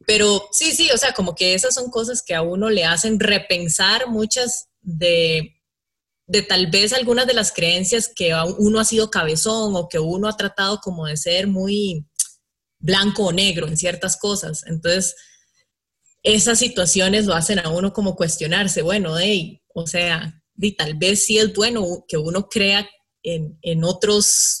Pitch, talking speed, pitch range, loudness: 190 Hz, 175 wpm, 170-215 Hz, -18 LUFS